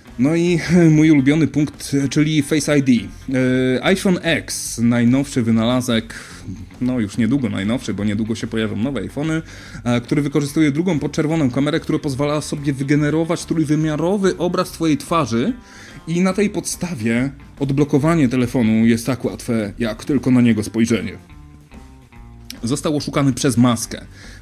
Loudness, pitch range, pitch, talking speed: -18 LUFS, 115-155 Hz, 140 Hz, 130 wpm